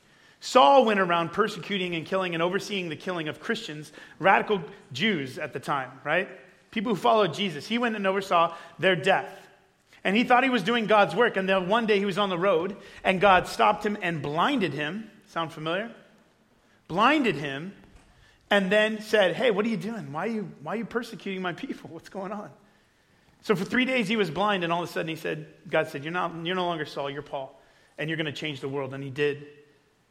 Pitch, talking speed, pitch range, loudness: 185 Hz, 220 wpm, 155-210 Hz, -26 LUFS